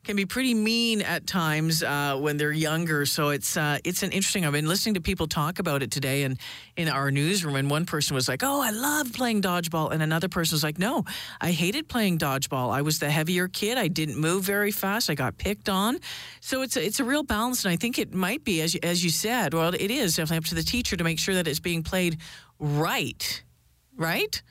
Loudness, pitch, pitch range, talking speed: -26 LUFS, 170 Hz, 155-205 Hz, 240 wpm